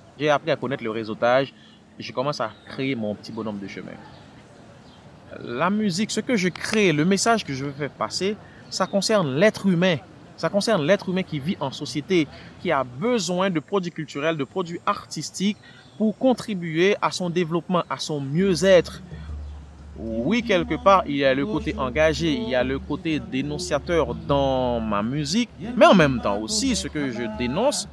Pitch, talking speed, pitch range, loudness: 160 Hz, 180 wpm, 135-195 Hz, -23 LUFS